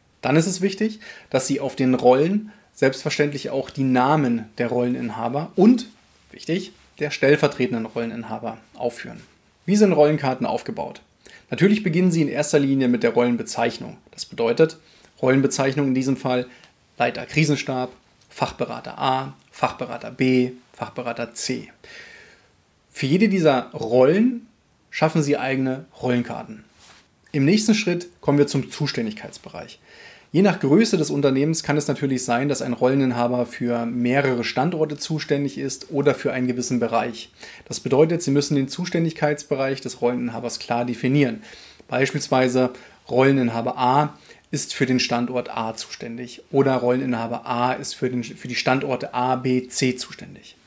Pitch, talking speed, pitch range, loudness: 135 Hz, 140 wpm, 125-150 Hz, -22 LUFS